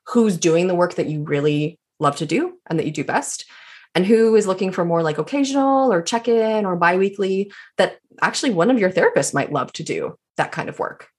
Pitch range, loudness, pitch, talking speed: 165-240 Hz, -20 LUFS, 195 Hz, 230 wpm